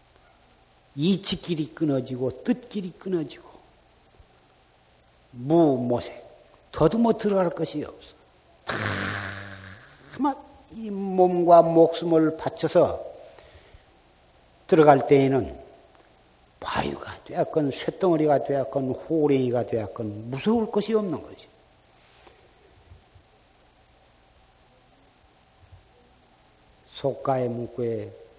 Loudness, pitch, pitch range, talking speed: -24 LUFS, 150 Hz, 120-185 Hz, 170 characters per minute